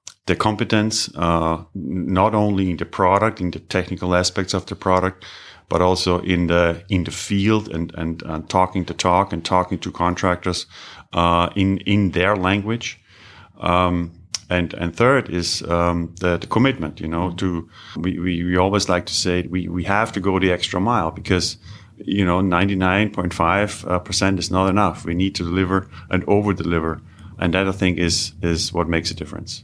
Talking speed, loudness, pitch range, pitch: 185 wpm, -20 LUFS, 85-100 Hz, 90 Hz